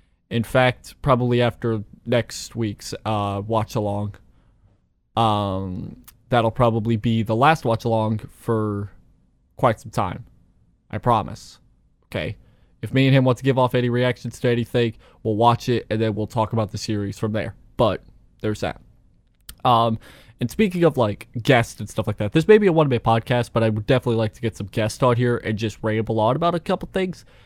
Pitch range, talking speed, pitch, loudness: 110-125 Hz, 190 wpm, 115 Hz, -22 LUFS